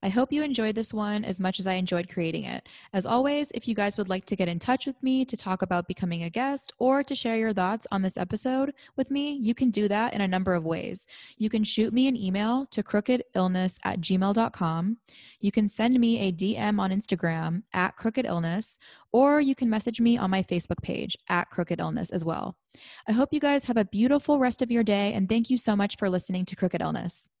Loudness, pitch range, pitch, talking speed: -27 LUFS, 185-250 Hz, 210 Hz, 230 wpm